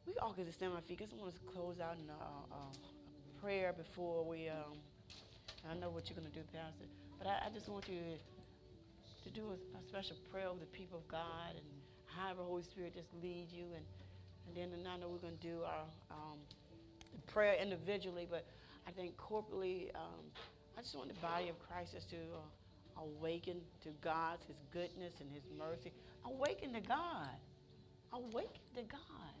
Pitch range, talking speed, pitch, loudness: 150-185 Hz, 190 wpm, 170 Hz, -47 LUFS